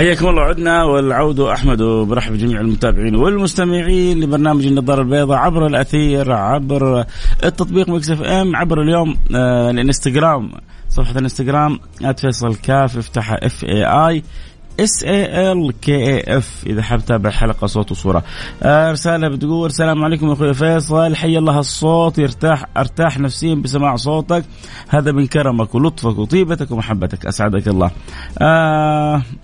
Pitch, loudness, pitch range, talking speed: 140 Hz, -15 LUFS, 120-160 Hz, 130 wpm